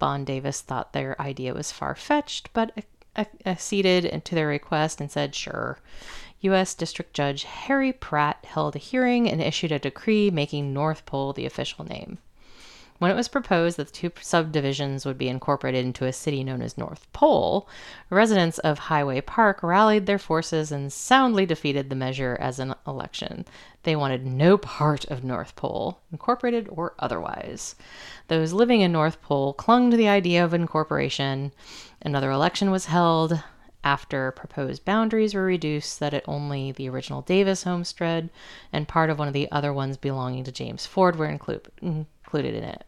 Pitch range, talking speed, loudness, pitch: 140-190 Hz, 175 wpm, -25 LUFS, 155 Hz